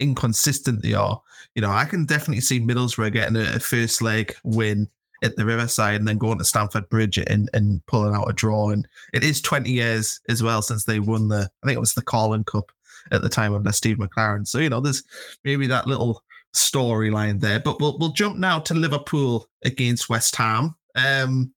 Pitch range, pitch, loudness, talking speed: 110-135 Hz, 115 Hz, -22 LUFS, 205 wpm